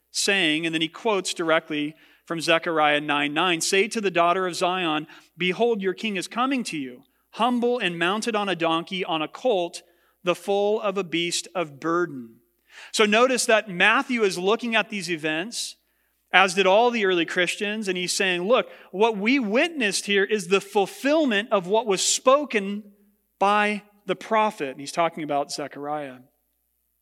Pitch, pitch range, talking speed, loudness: 185 Hz, 165-210 Hz, 170 wpm, -23 LUFS